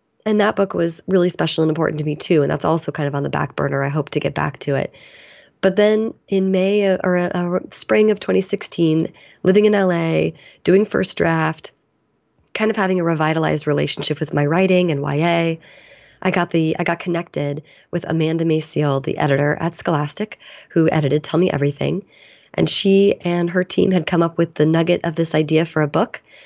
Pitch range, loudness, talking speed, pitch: 155-185 Hz, -19 LUFS, 200 wpm, 170 Hz